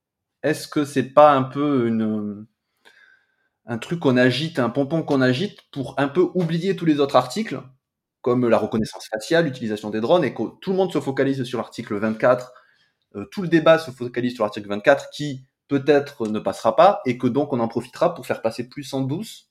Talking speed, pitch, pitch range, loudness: 200 wpm, 135 Hz, 120-160 Hz, -21 LUFS